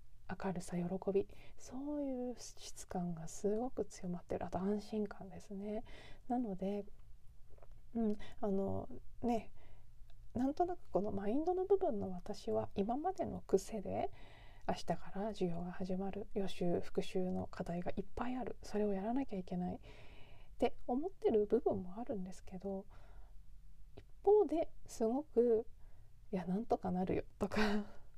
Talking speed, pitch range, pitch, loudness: 275 characters per minute, 185-235 Hz, 205 Hz, -40 LUFS